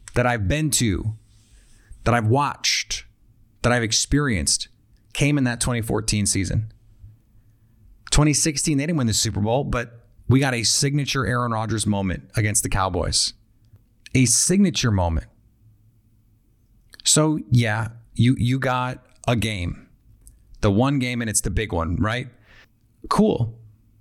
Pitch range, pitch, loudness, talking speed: 110-125 Hz, 110 Hz, -21 LUFS, 130 wpm